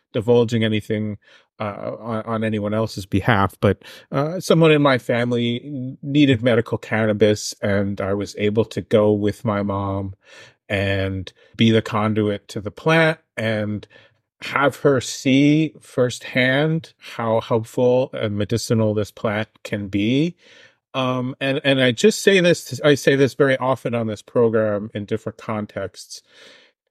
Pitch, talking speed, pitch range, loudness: 115 Hz, 140 wpm, 105-130 Hz, -20 LUFS